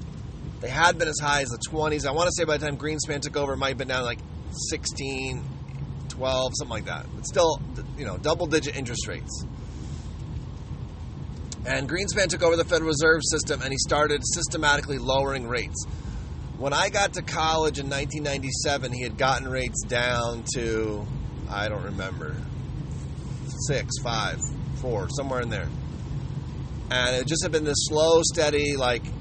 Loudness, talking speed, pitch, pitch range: -26 LUFS, 165 wpm, 135 Hz, 125-150 Hz